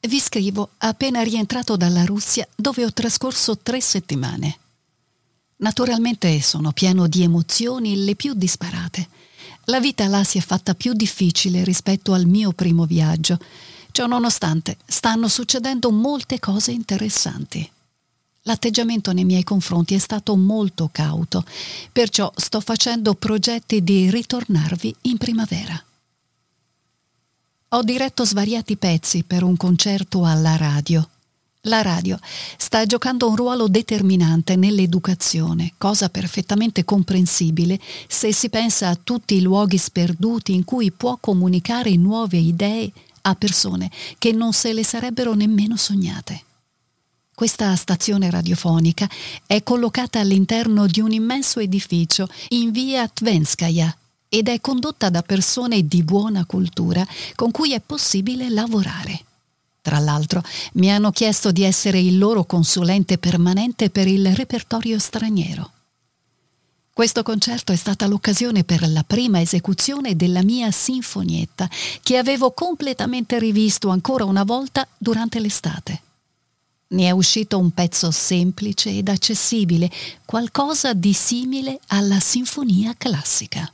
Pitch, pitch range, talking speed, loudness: 200 Hz, 175-230 Hz, 125 wpm, -19 LUFS